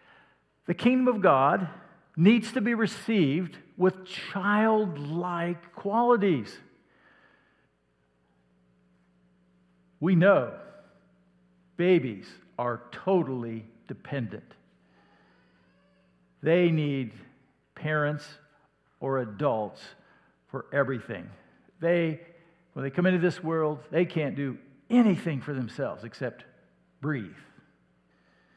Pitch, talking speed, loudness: 150 Hz, 80 wpm, -27 LUFS